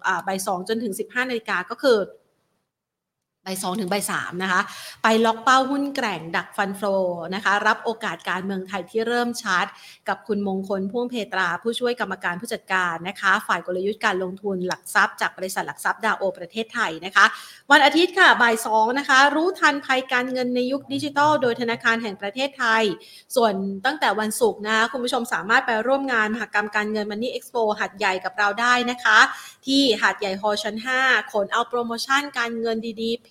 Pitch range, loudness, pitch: 195-245 Hz, -22 LUFS, 220 Hz